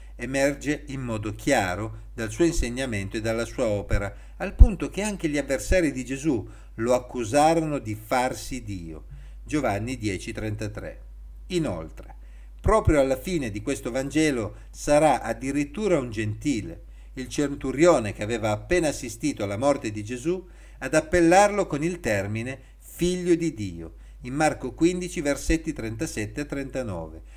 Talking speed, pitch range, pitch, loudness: 130 wpm, 105-150 Hz, 130 Hz, -26 LUFS